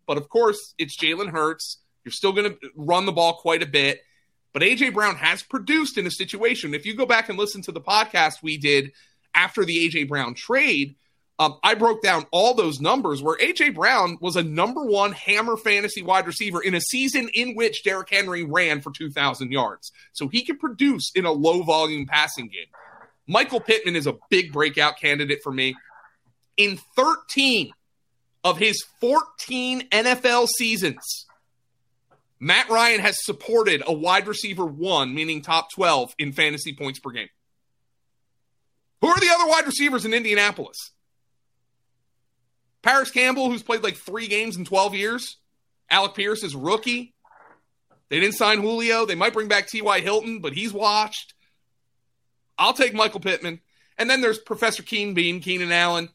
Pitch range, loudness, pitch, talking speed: 150-230 Hz, -21 LUFS, 195 Hz, 170 wpm